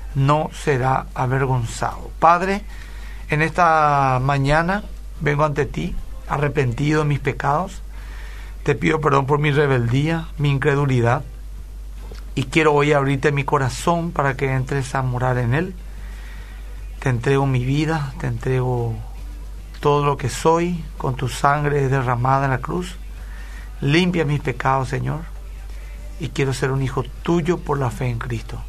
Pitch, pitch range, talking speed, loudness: 140 Hz, 125-150 Hz, 140 wpm, -20 LUFS